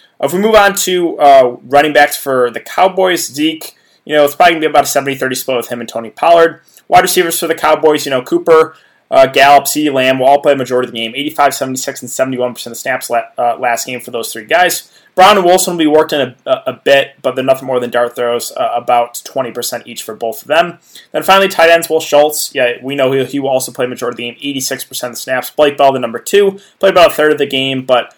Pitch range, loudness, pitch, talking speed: 125-165 Hz, -12 LUFS, 140 Hz, 265 wpm